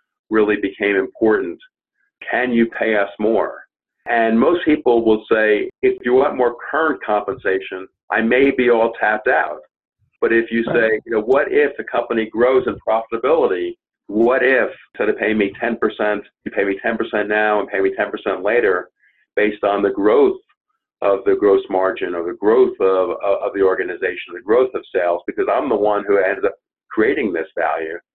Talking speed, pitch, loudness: 180 wpm, 120 Hz, -18 LUFS